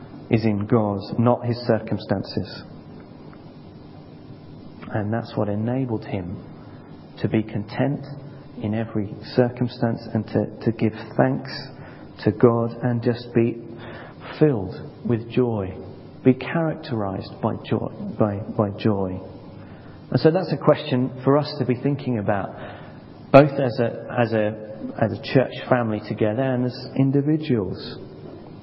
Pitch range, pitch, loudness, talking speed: 110-130 Hz, 115 Hz, -23 LUFS, 130 wpm